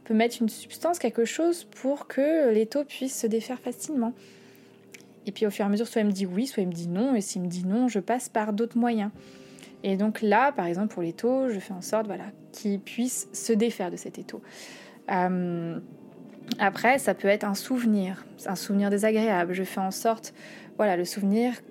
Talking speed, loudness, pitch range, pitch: 220 wpm, -27 LUFS, 195-240 Hz, 220 Hz